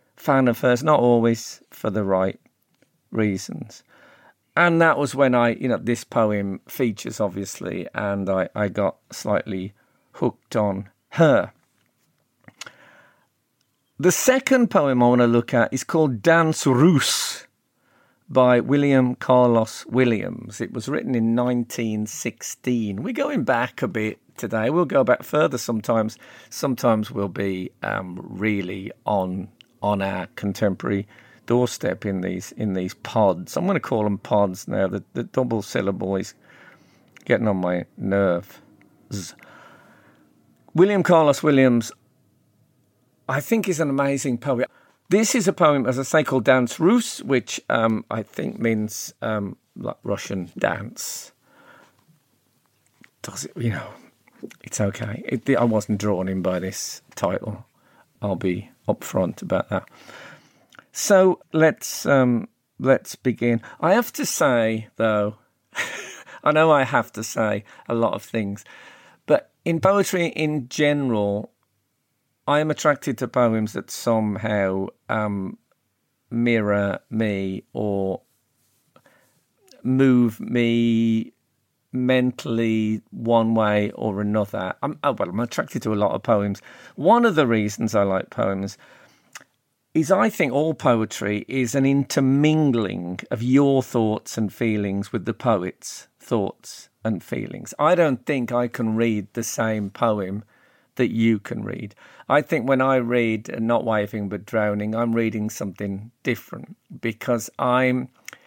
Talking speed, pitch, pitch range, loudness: 135 wpm, 115 Hz, 105-130 Hz, -22 LUFS